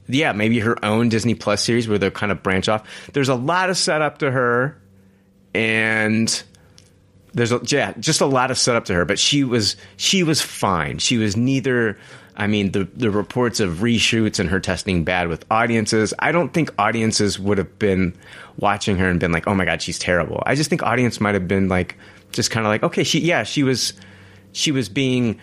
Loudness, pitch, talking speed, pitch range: -19 LUFS, 110 Hz, 210 wpm, 95-125 Hz